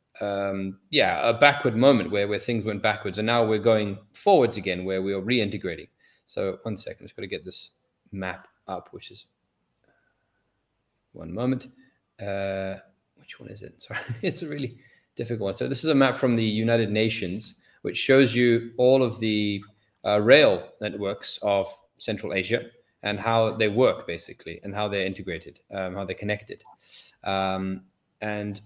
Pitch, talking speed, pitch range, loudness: 105 Hz, 165 wpm, 100-120 Hz, -25 LUFS